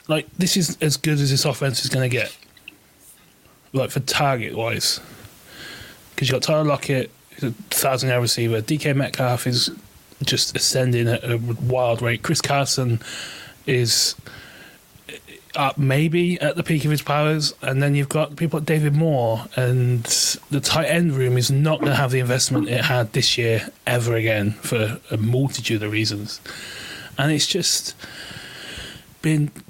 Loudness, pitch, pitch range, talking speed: -20 LUFS, 135 Hz, 120-150 Hz, 160 wpm